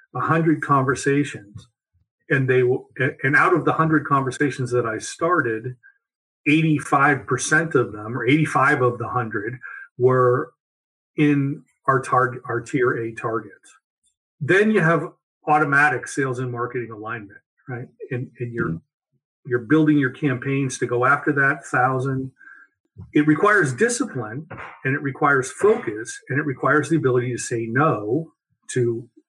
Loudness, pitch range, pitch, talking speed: -21 LUFS, 125-155 Hz, 135 Hz, 140 wpm